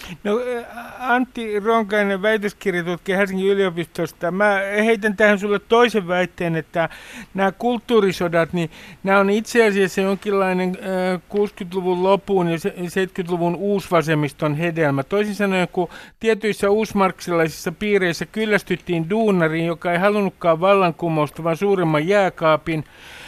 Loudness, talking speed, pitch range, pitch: -20 LUFS, 110 wpm, 175-205 Hz, 195 Hz